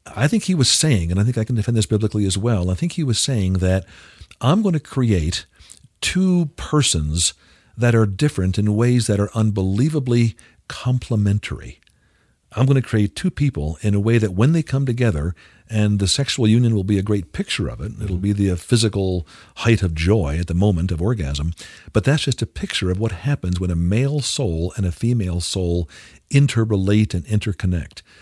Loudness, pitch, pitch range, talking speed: -20 LUFS, 105 Hz, 95-120 Hz, 195 wpm